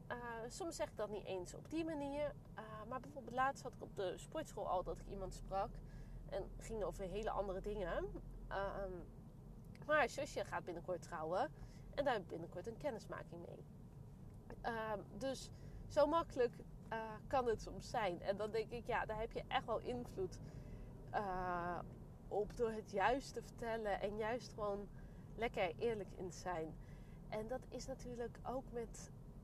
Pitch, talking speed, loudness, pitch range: 205 Hz, 175 wpm, -44 LUFS, 175-235 Hz